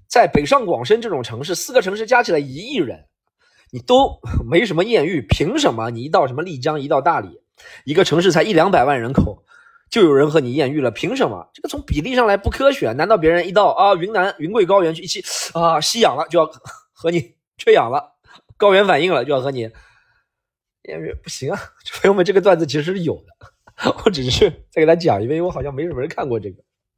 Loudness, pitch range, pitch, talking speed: -17 LUFS, 145-200 Hz, 165 Hz, 325 characters per minute